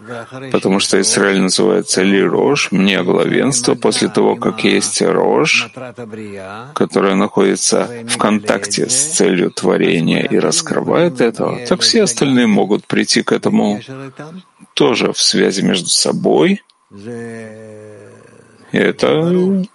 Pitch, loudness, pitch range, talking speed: 120 Hz, -13 LUFS, 105-160 Hz, 110 wpm